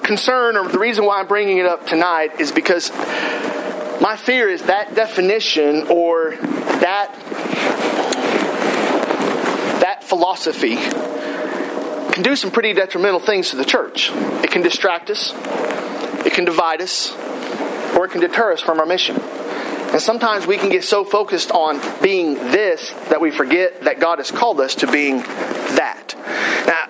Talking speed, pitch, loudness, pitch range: 150 wpm, 200 Hz, -17 LUFS, 175-230 Hz